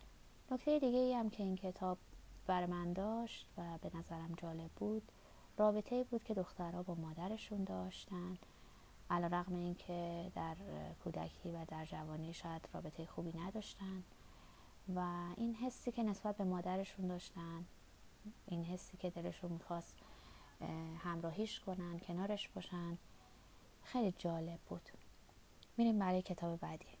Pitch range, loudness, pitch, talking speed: 170-205 Hz, -43 LUFS, 180 Hz, 130 wpm